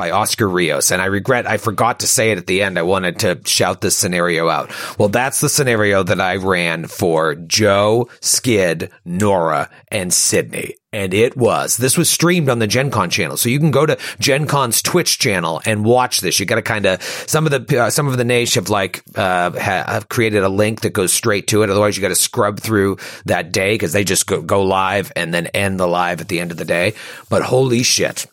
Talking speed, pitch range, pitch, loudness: 230 wpm, 95-125 Hz, 105 Hz, -16 LUFS